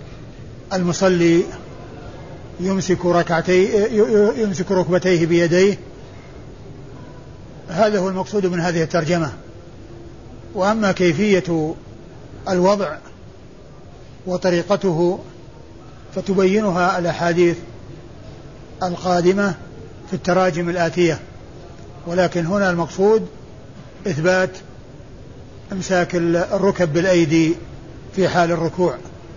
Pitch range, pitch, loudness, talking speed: 165-190 Hz, 175 Hz, -18 LUFS, 65 wpm